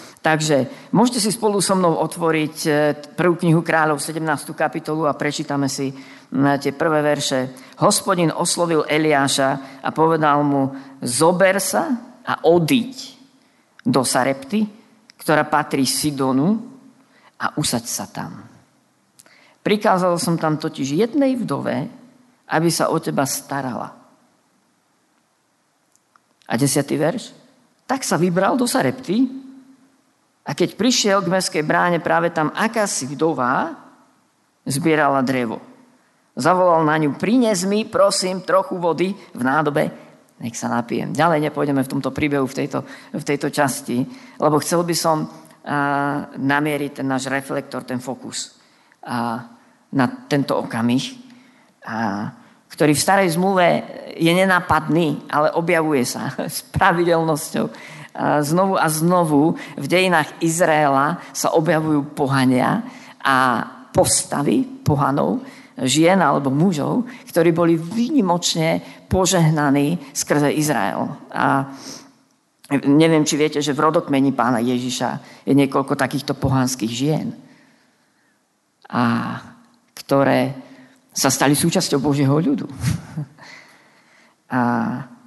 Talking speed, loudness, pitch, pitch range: 115 wpm, -19 LUFS, 155 Hz, 140-190 Hz